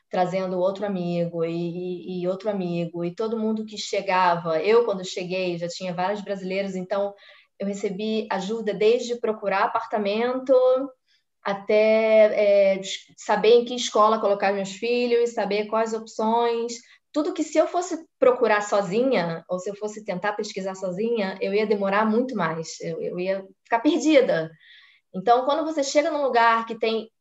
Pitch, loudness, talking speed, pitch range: 210 Hz, -23 LUFS, 155 wpm, 190-235 Hz